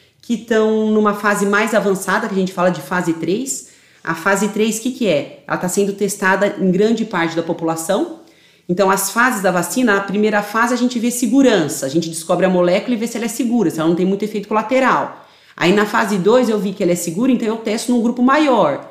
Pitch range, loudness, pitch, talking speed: 185-235 Hz, -17 LUFS, 205 Hz, 240 wpm